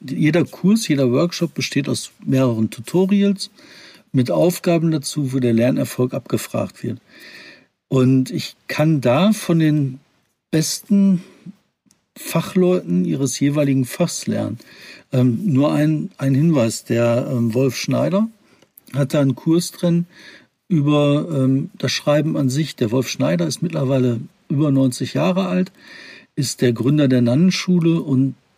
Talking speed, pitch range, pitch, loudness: 130 wpm, 130-175 Hz, 150 Hz, -19 LUFS